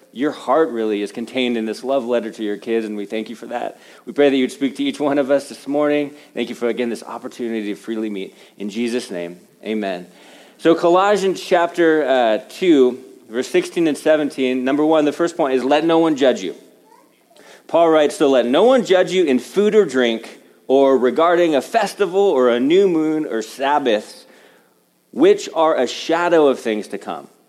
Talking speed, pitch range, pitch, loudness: 205 wpm, 115-165 Hz, 140 Hz, -18 LUFS